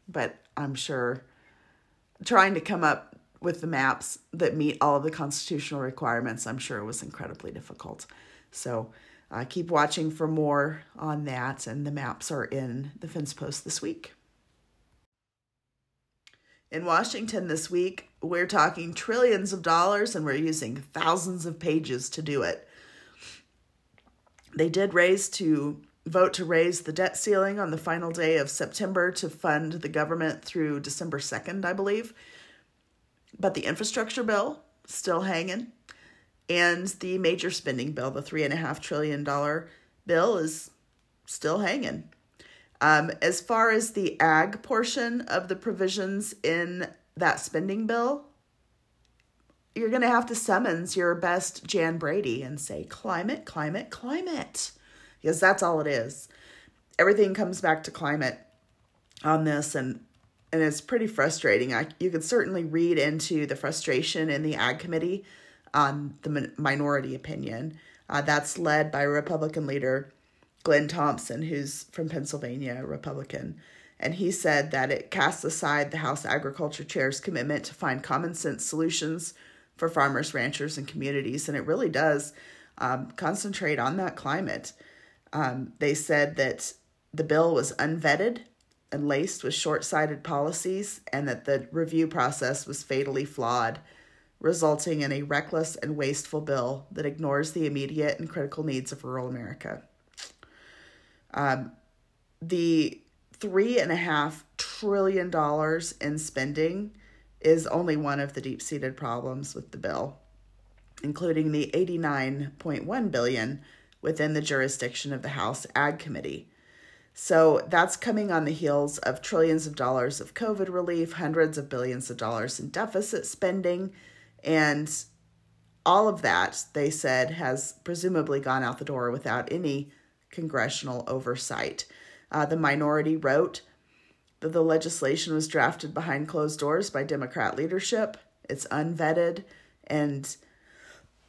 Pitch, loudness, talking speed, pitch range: 155 Hz, -28 LUFS, 140 wpm, 140-170 Hz